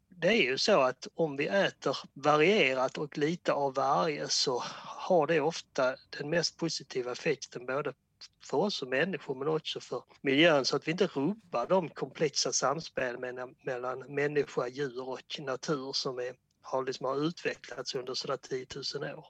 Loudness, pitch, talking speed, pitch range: -31 LUFS, 145 Hz, 170 wpm, 130-160 Hz